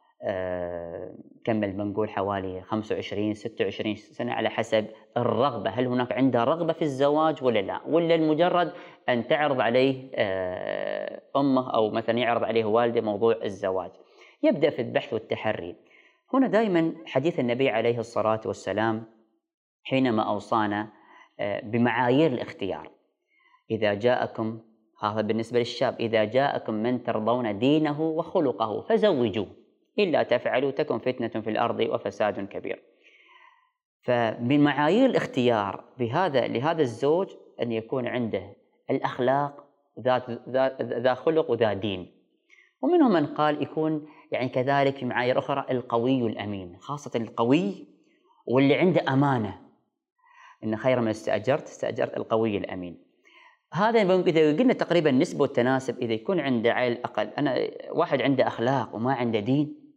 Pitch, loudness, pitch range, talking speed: 125 Hz, -26 LUFS, 110-160 Hz, 120 wpm